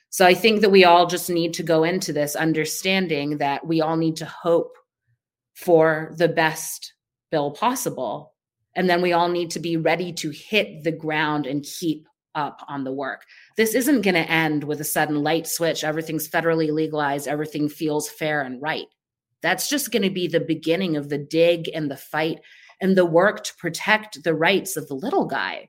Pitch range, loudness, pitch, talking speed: 150-175 Hz, -22 LUFS, 160 Hz, 195 wpm